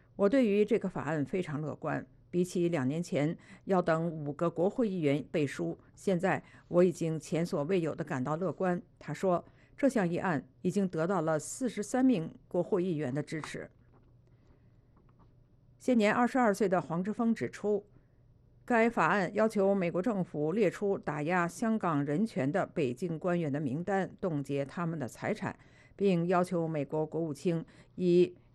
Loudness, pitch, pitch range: -32 LUFS, 170 Hz, 145-195 Hz